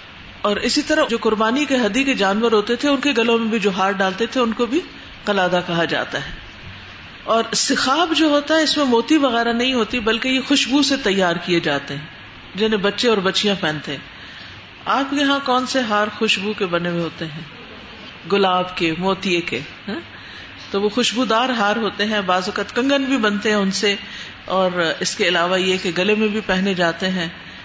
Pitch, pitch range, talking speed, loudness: 210 Hz, 180-245 Hz, 205 wpm, -18 LUFS